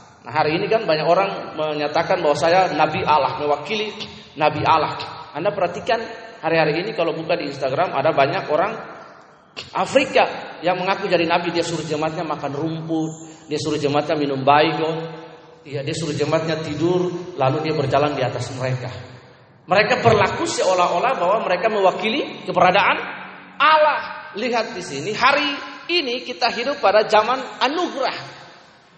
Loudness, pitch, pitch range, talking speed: -20 LUFS, 165 Hz, 150-195 Hz, 140 wpm